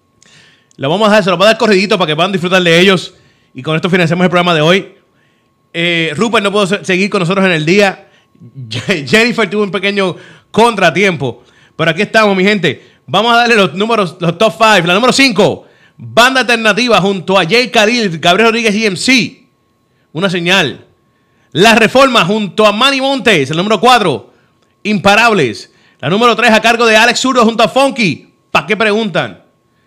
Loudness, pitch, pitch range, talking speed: -10 LUFS, 200 Hz, 170-220 Hz, 185 wpm